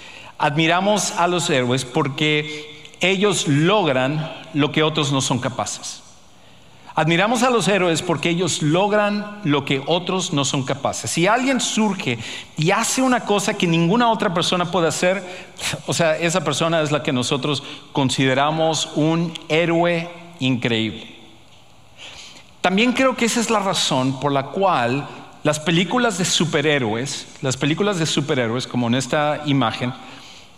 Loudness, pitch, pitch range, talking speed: -19 LUFS, 160 Hz, 140-185 Hz, 145 wpm